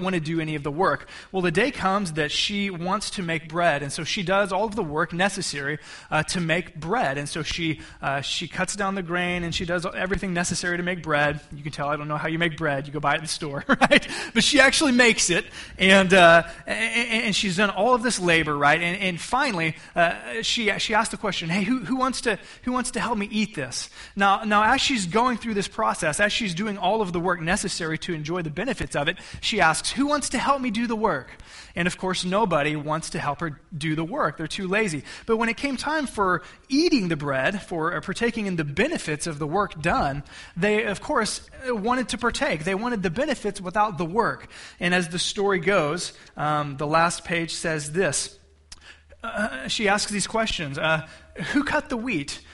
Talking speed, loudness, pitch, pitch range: 230 wpm, -23 LUFS, 185 Hz, 160-220 Hz